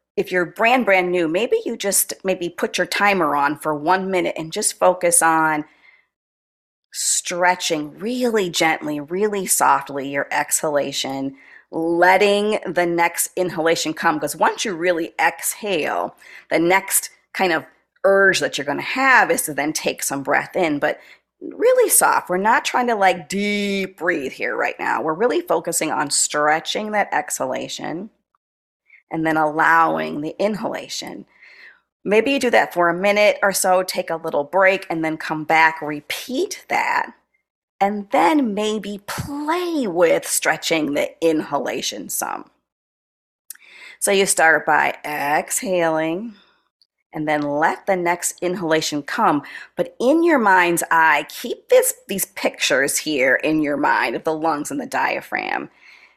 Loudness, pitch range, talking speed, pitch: -19 LUFS, 160-210 Hz, 145 wpm, 180 Hz